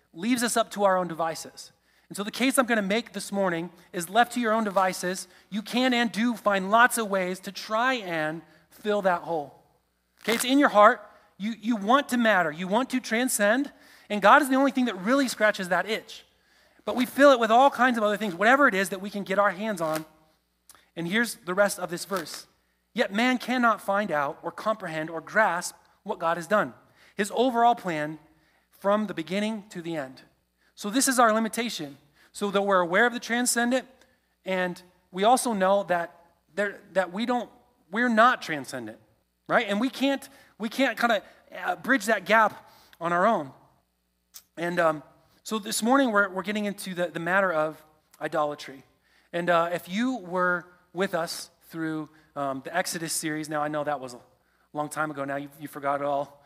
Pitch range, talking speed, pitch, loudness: 165-230 Hz, 200 wpm, 195 Hz, -25 LUFS